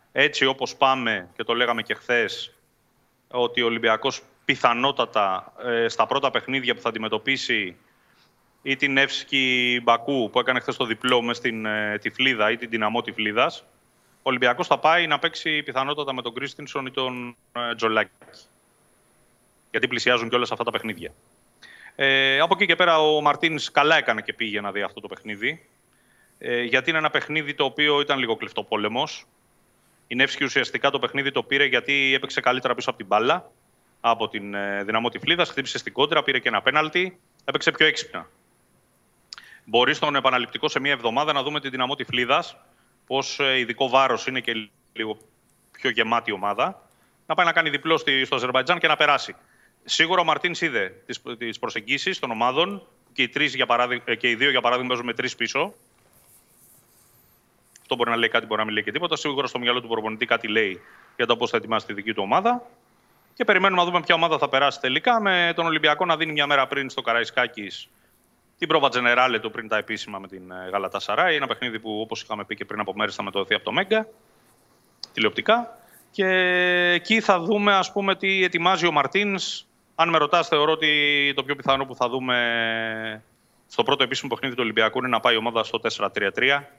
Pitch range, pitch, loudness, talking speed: 115-155 Hz, 135 Hz, -22 LUFS, 185 wpm